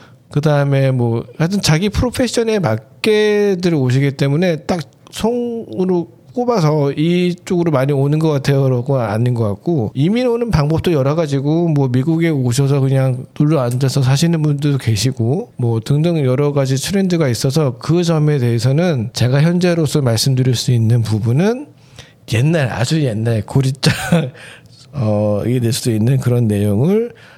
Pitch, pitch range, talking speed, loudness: 140 Hz, 125-165 Hz, 315 characters per minute, -16 LUFS